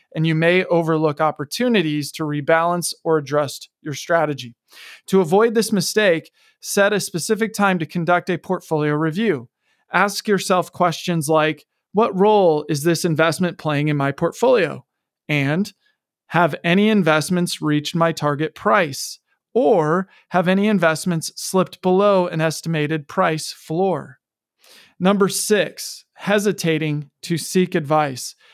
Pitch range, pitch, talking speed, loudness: 155-195 Hz, 170 Hz, 130 wpm, -19 LUFS